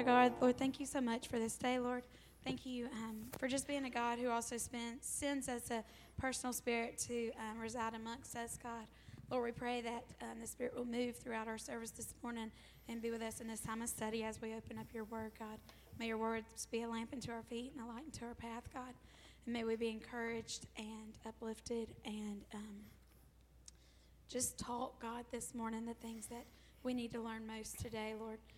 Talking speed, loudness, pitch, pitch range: 215 wpm, -43 LUFS, 230 Hz, 225-245 Hz